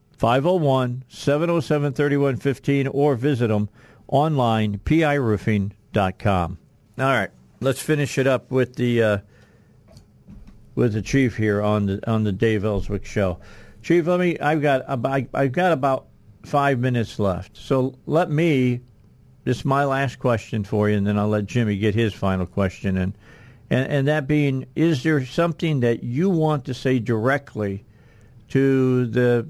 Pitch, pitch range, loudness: 125 Hz, 105-140 Hz, -22 LUFS